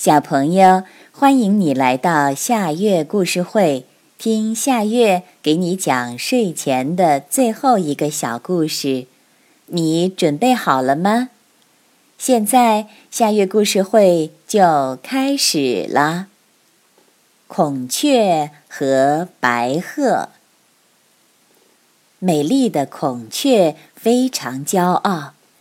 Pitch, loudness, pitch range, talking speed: 180 Hz, -17 LUFS, 145-225 Hz, 140 characters per minute